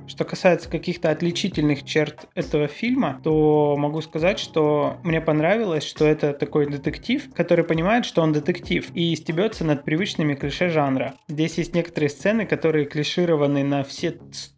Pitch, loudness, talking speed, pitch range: 160 Hz, -22 LUFS, 150 wpm, 150-175 Hz